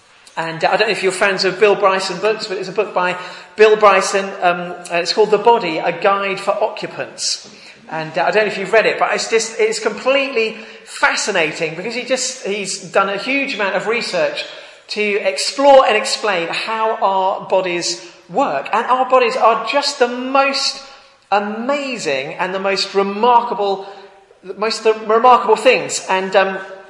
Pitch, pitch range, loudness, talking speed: 205 Hz, 190-240 Hz, -16 LUFS, 175 wpm